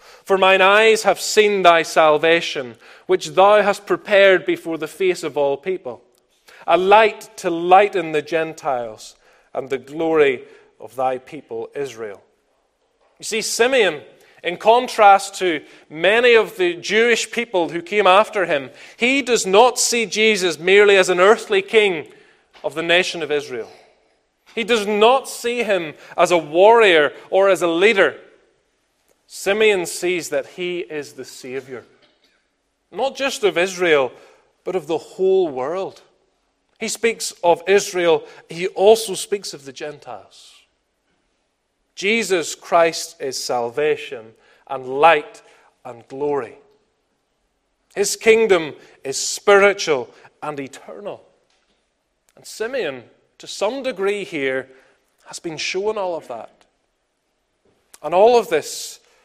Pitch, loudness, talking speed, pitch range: 200 Hz, -17 LUFS, 130 wpm, 170-270 Hz